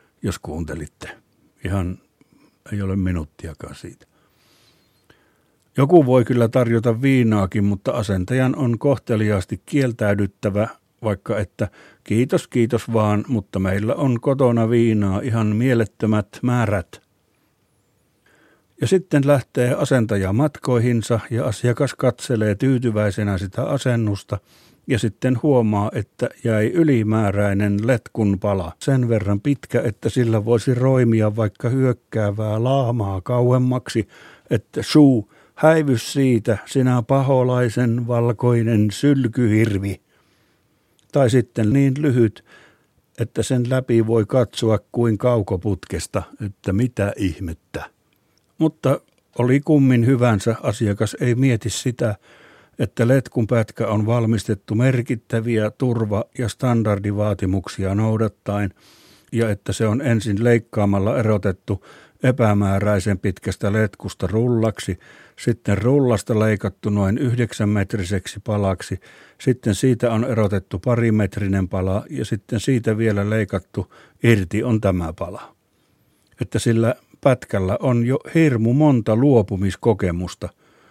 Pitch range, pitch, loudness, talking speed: 105-125 Hz, 115 Hz, -20 LUFS, 105 wpm